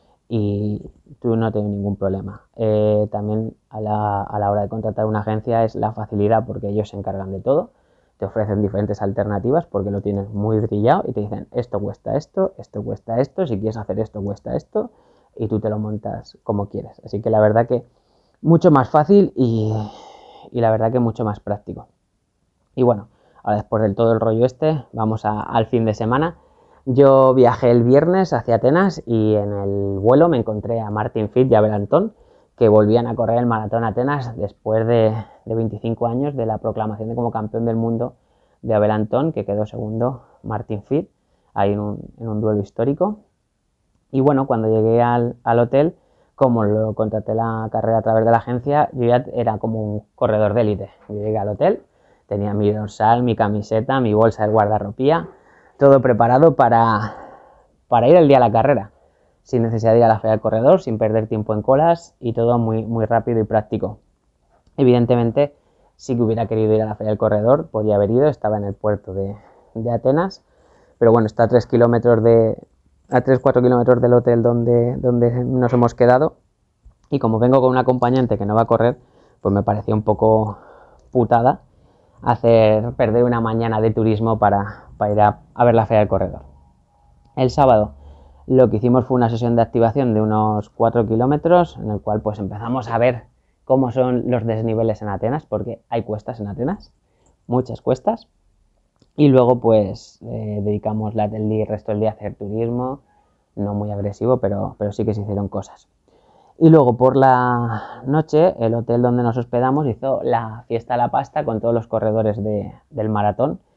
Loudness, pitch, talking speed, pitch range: -18 LUFS, 115 Hz, 190 wpm, 105-125 Hz